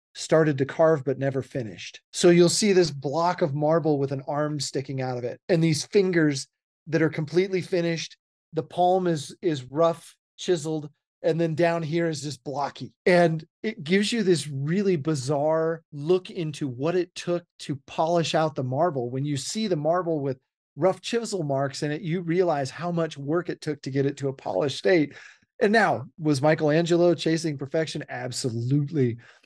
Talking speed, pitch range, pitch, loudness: 180 wpm, 140-175 Hz, 160 Hz, -25 LUFS